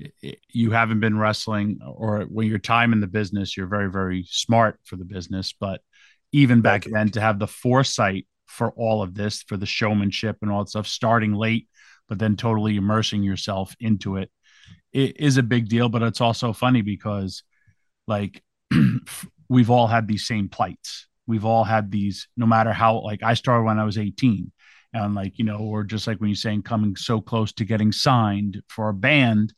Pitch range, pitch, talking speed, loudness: 105-115 Hz, 110 Hz, 195 wpm, -22 LUFS